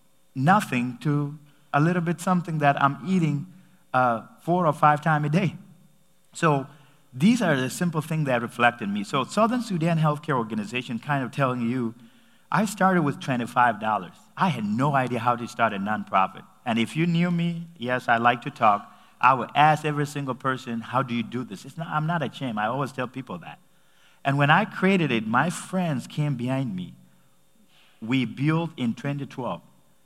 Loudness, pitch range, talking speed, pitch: -24 LUFS, 125-170 Hz, 185 wpm, 145 Hz